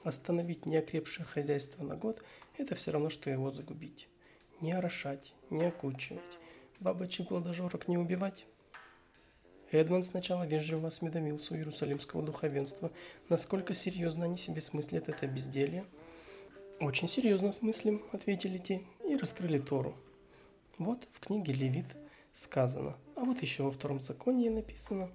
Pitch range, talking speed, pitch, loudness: 145-185 Hz, 125 wpm, 165 Hz, -36 LUFS